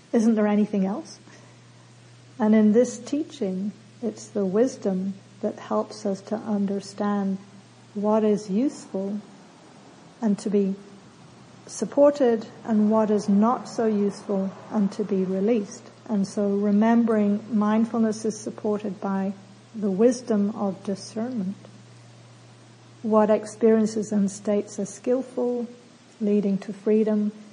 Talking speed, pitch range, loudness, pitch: 115 wpm, 200-220 Hz, -24 LUFS, 210 Hz